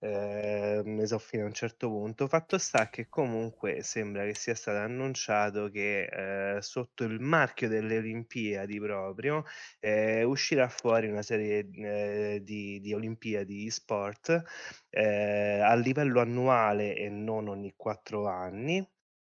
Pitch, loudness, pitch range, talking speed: 110 Hz, -31 LUFS, 105-120 Hz, 140 wpm